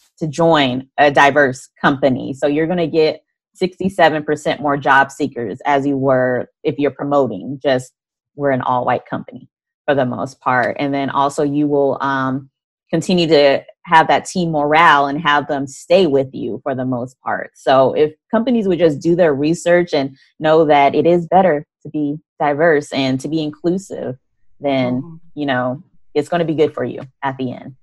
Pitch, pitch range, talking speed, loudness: 145 Hz, 135-160 Hz, 185 wpm, -16 LUFS